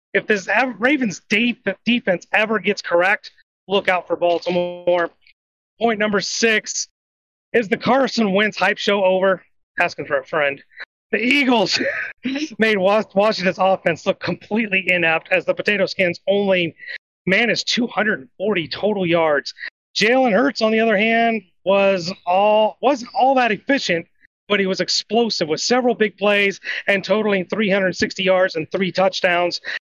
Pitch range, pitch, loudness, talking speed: 185-220 Hz, 195 Hz, -18 LUFS, 140 wpm